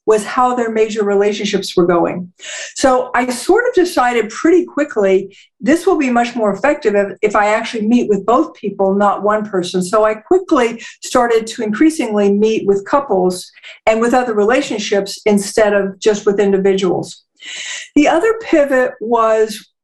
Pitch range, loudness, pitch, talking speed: 200-255 Hz, -14 LUFS, 220 Hz, 160 wpm